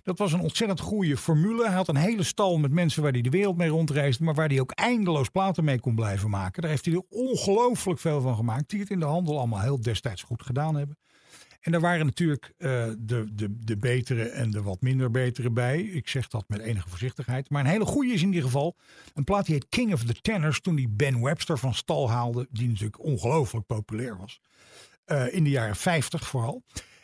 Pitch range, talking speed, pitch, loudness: 120-170 Hz, 230 wpm, 145 Hz, -27 LUFS